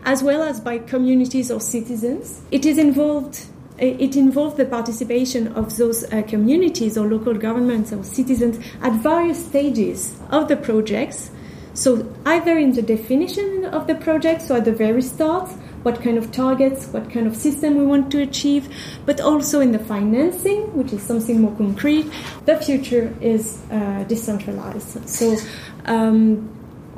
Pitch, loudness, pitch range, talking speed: 255 Hz, -19 LUFS, 225-290 Hz, 160 wpm